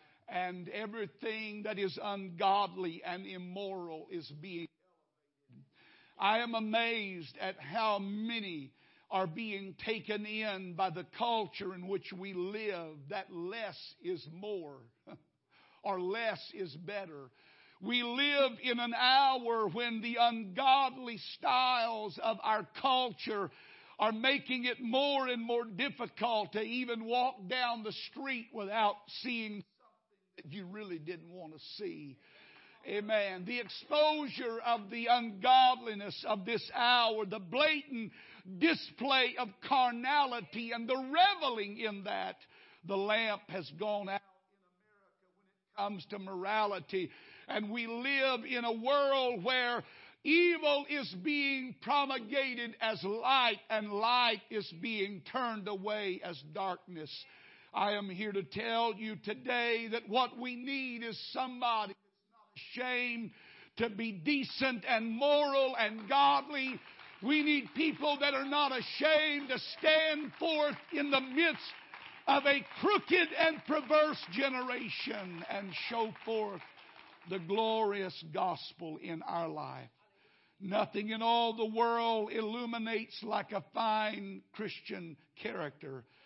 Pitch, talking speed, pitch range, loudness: 220 Hz, 125 wpm, 195-255 Hz, -34 LUFS